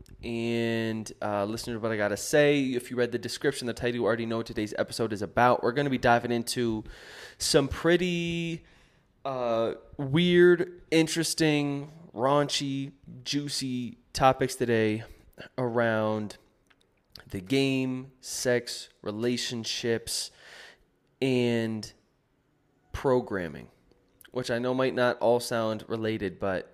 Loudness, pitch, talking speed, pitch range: -28 LUFS, 120 Hz, 125 wpm, 115-135 Hz